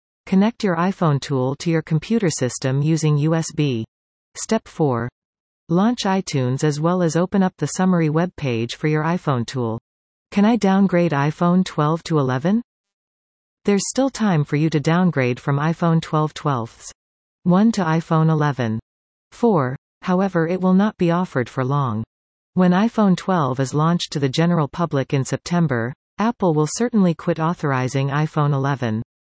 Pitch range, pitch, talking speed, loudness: 135-180 Hz, 160 Hz, 155 wpm, -20 LUFS